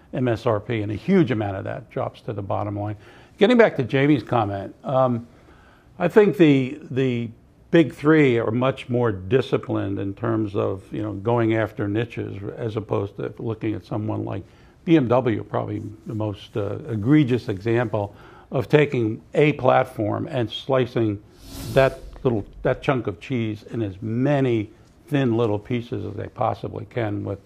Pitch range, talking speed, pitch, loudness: 105-130 Hz, 160 wpm, 115 Hz, -23 LUFS